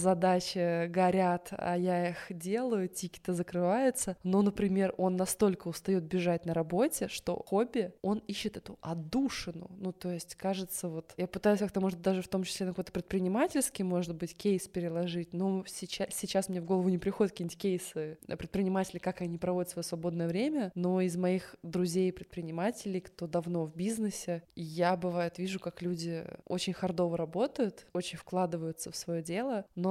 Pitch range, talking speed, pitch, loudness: 175-195 Hz, 165 wpm, 185 Hz, -33 LUFS